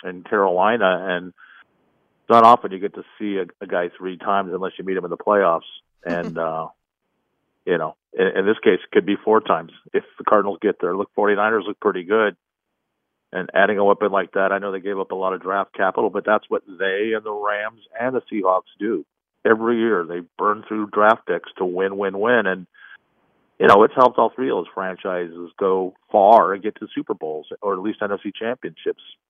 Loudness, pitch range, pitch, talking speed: -20 LUFS, 90-105 Hz, 100 Hz, 215 wpm